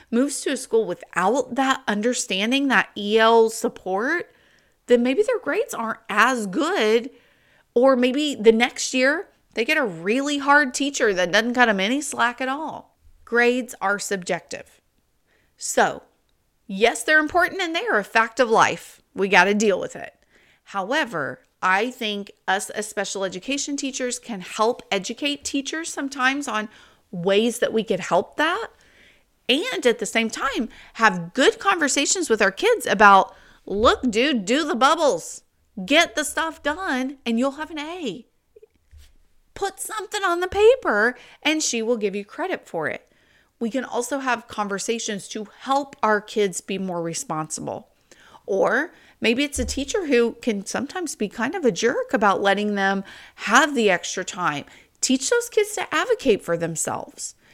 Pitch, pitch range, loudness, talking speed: 245 Hz, 210-290 Hz, -21 LUFS, 160 wpm